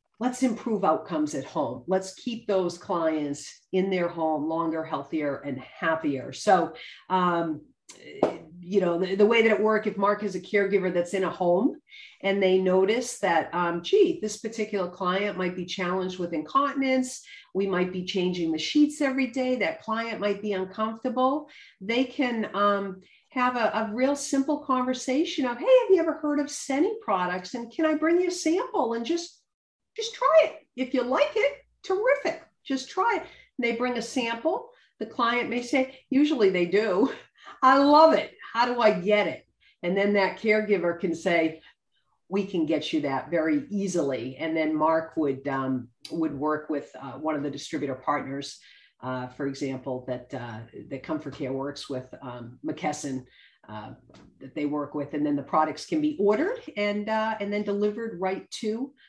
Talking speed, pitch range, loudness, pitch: 180 wpm, 160-260 Hz, -26 LUFS, 205 Hz